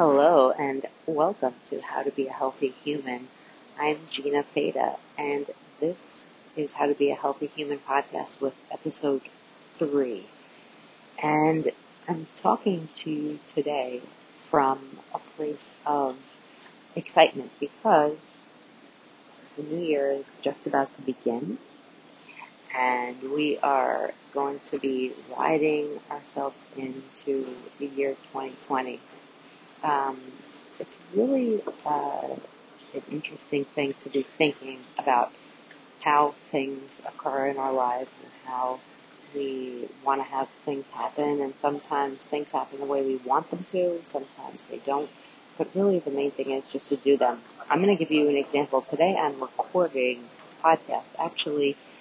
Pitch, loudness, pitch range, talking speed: 140 Hz, -27 LUFS, 135-150 Hz, 135 wpm